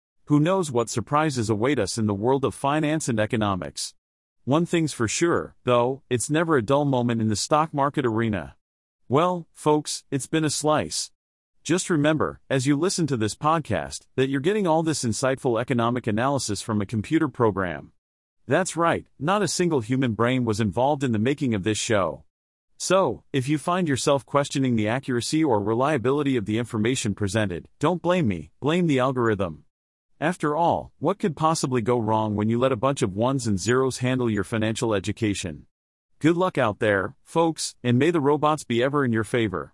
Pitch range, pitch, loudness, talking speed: 110-150 Hz, 130 Hz, -24 LUFS, 185 wpm